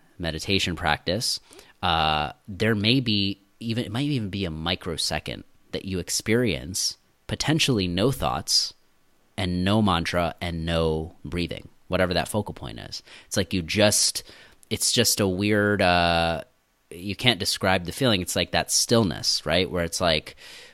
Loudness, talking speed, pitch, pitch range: -24 LUFS, 150 wpm, 95 Hz, 85-110 Hz